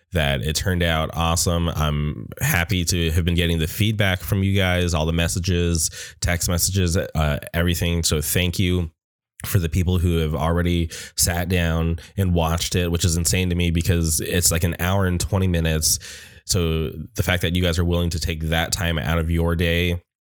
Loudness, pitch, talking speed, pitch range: -21 LUFS, 85 Hz, 195 wpm, 85-90 Hz